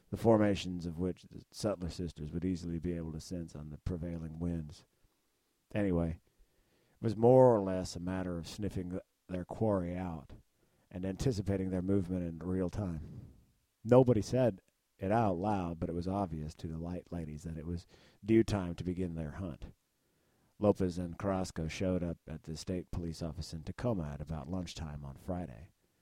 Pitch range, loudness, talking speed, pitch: 85-100 Hz, -35 LUFS, 175 wpm, 90 Hz